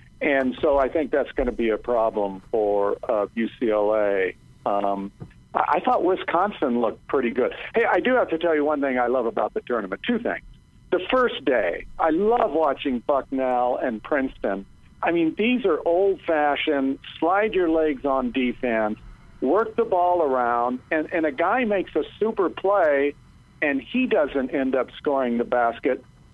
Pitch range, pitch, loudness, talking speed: 120-170 Hz, 140 Hz, -23 LUFS, 175 wpm